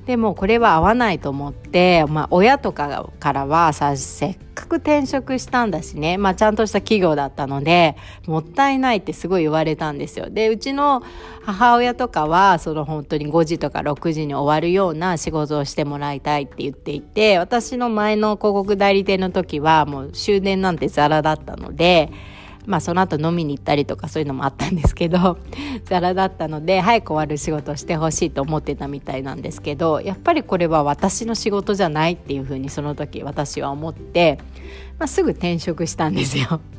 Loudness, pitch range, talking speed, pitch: -19 LUFS, 150-200 Hz, 390 characters per minute, 165 Hz